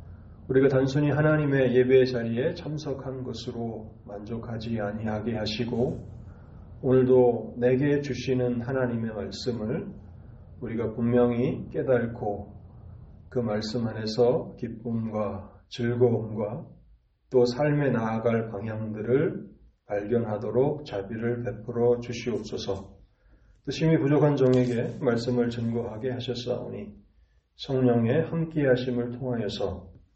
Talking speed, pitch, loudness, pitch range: 255 characters per minute, 120 Hz, -27 LUFS, 105-125 Hz